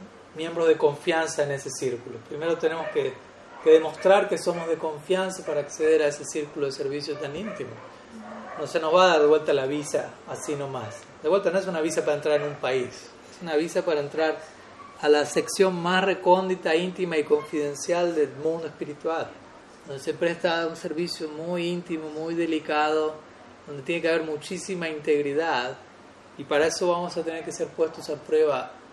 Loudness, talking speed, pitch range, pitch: -25 LUFS, 185 wpm, 150-175 Hz, 160 Hz